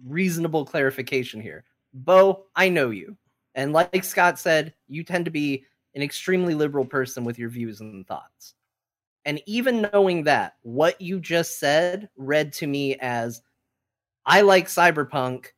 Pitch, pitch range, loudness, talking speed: 145 Hz, 130-175 Hz, -22 LUFS, 150 wpm